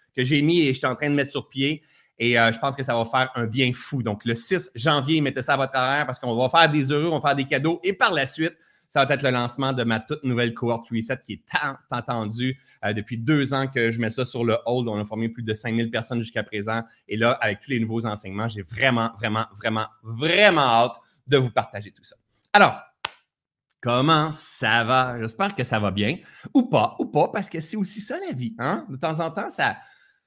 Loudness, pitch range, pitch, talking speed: -23 LUFS, 115-150 Hz, 130 Hz, 250 wpm